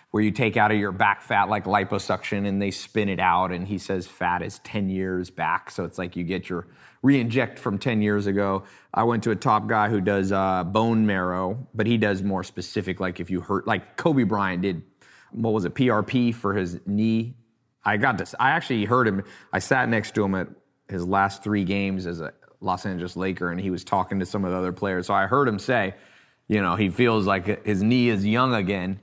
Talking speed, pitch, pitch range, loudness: 235 wpm, 100 Hz, 95-110 Hz, -24 LUFS